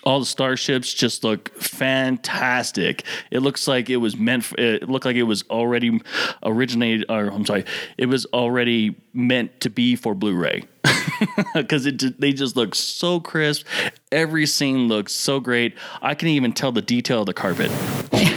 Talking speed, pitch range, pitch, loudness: 175 wpm, 120-140 Hz, 125 Hz, -21 LUFS